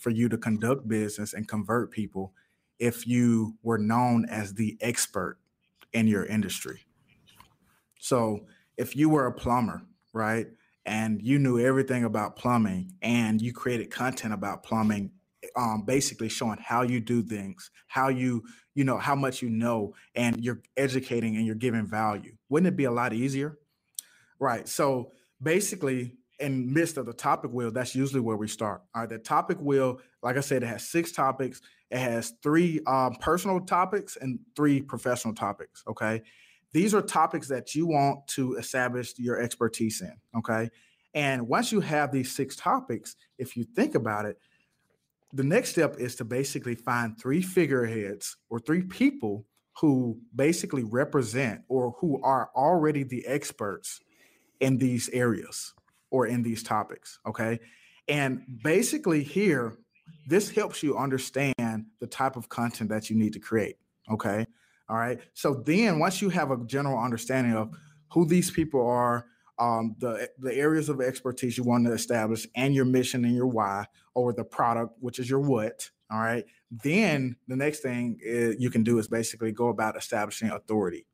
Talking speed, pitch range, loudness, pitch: 165 wpm, 115-140 Hz, -28 LUFS, 125 Hz